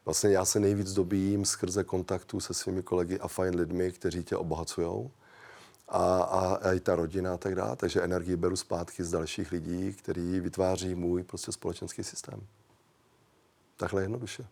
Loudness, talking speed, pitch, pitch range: -31 LUFS, 160 wpm, 95 Hz, 90-100 Hz